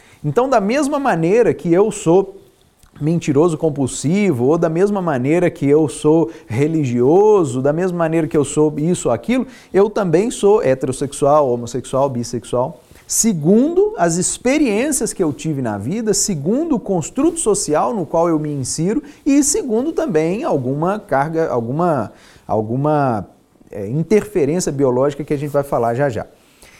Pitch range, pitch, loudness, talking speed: 145-210 Hz, 165 Hz, -17 LUFS, 145 wpm